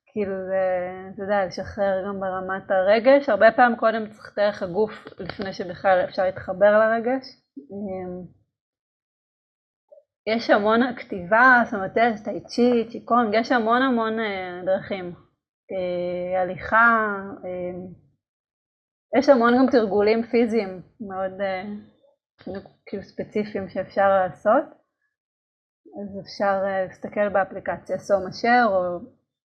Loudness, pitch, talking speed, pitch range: -22 LUFS, 205 Hz, 90 wpm, 190-235 Hz